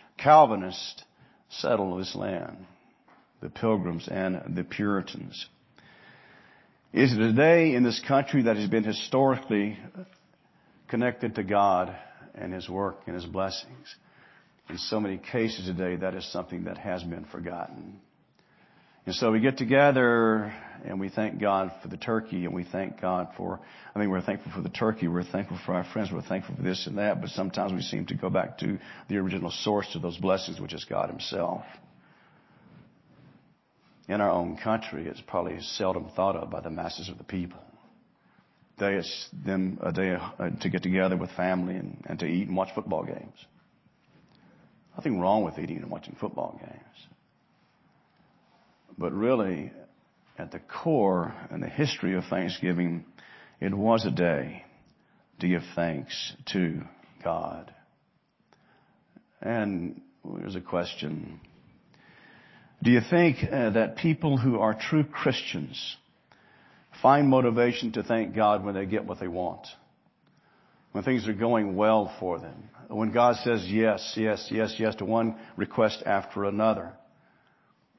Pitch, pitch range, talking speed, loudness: 100 Hz, 90-115 Hz, 150 wpm, -28 LUFS